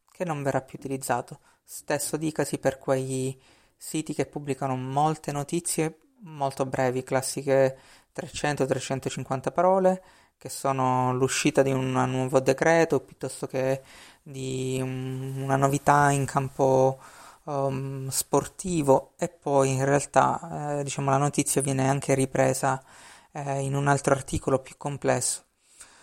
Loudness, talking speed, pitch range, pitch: -26 LUFS, 125 wpm, 130-145 Hz, 135 Hz